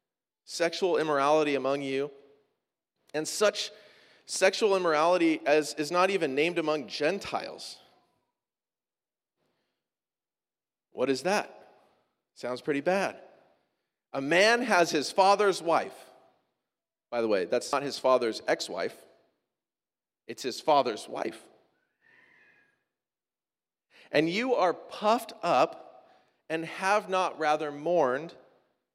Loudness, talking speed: -28 LUFS, 105 wpm